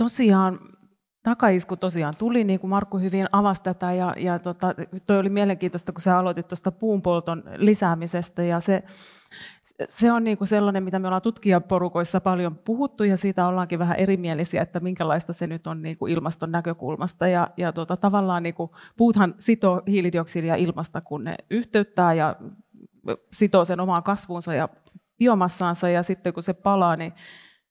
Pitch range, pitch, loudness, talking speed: 170-200 Hz, 185 Hz, -23 LUFS, 160 wpm